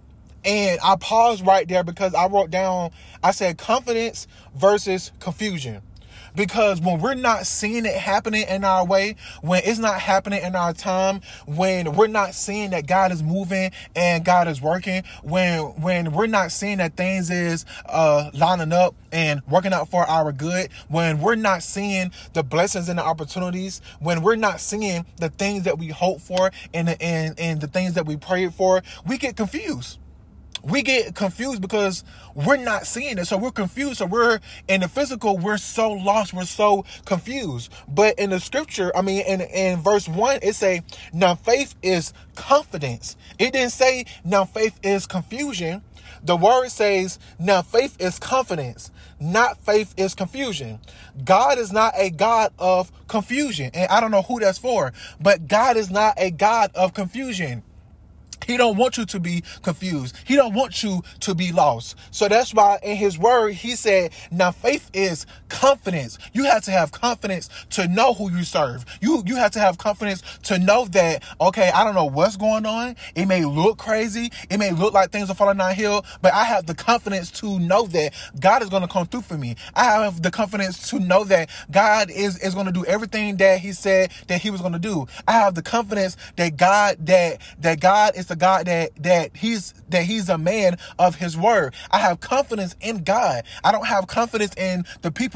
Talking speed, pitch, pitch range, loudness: 195 wpm, 190 Hz, 175-210 Hz, -21 LUFS